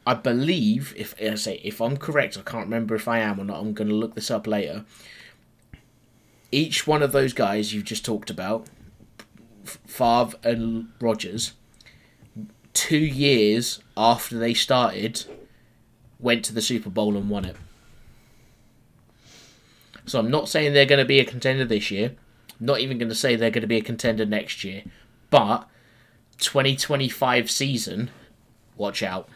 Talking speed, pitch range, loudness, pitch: 160 wpm, 110-130 Hz, -23 LUFS, 115 Hz